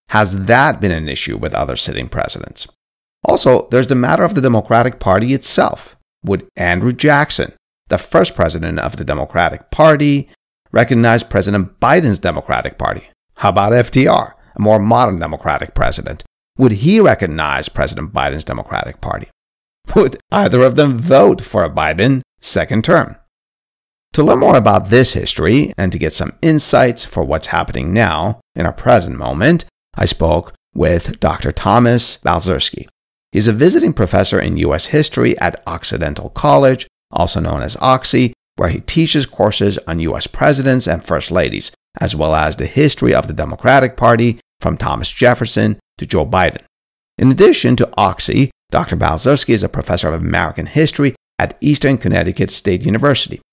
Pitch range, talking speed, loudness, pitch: 90-130 Hz, 155 wpm, -14 LUFS, 115 Hz